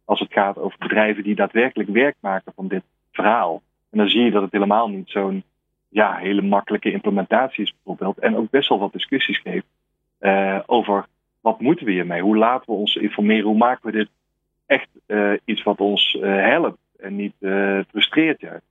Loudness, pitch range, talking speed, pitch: -20 LUFS, 100-110 Hz, 200 wpm, 105 Hz